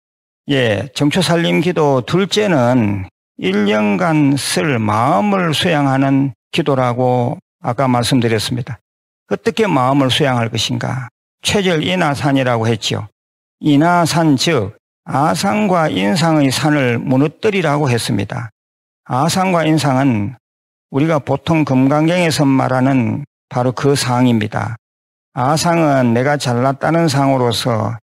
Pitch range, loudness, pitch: 120-160 Hz, -15 LUFS, 135 Hz